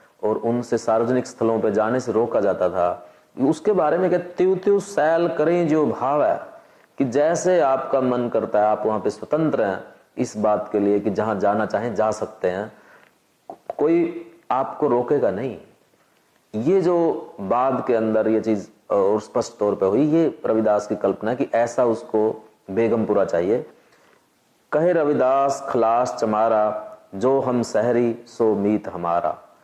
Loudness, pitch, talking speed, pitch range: -21 LUFS, 120 Hz, 150 wpm, 110-150 Hz